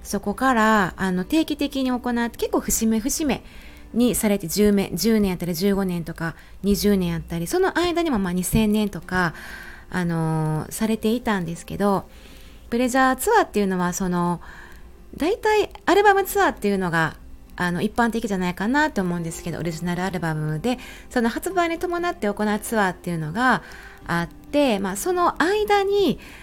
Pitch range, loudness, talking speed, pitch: 180-265 Hz, -22 LUFS, 310 characters per minute, 210 Hz